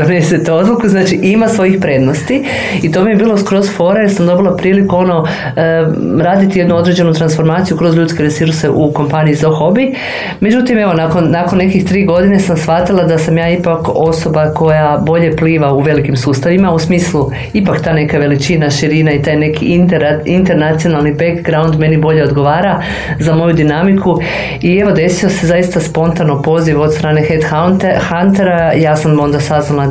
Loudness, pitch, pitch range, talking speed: -10 LUFS, 165 Hz, 155-180 Hz, 165 wpm